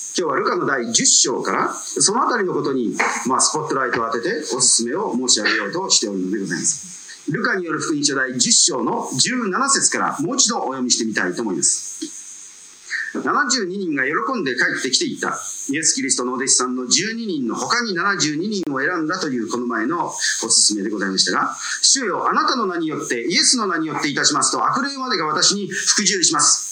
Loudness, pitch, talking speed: -18 LUFS, 245 Hz, 405 characters per minute